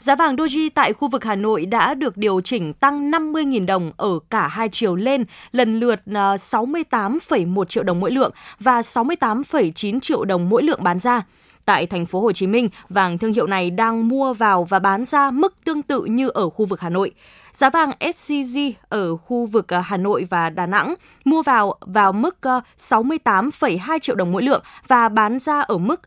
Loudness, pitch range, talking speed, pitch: -19 LUFS, 195-275 Hz, 195 wpm, 230 Hz